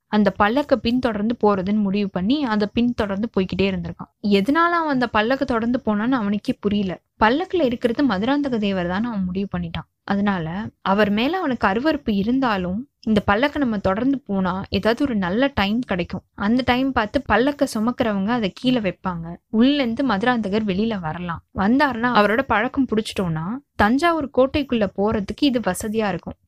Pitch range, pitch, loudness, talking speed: 200-255 Hz, 220 Hz, -21 LUFS, 145 wpm